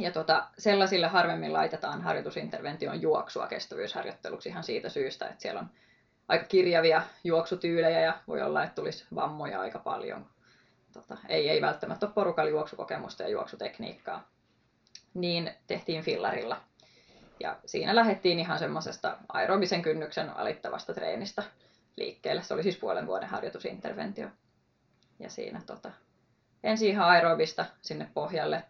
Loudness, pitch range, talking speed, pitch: -30 LUFS, 165-205 Hz, 125 wpm, 175 Hz